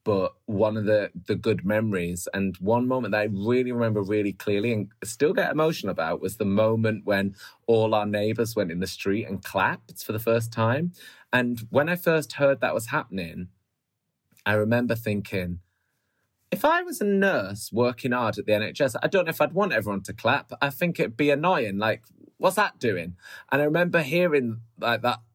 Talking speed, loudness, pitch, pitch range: 195 wpm, -25 LUFS, 110 Hz, 100-135 Hz